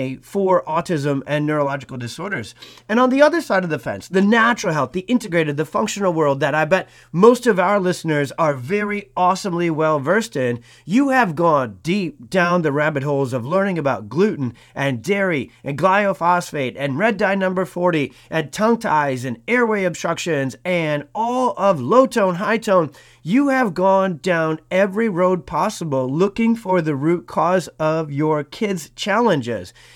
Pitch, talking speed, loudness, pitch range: 175 Hz, 170 wpm, -19 LUFS, 150-200 Hz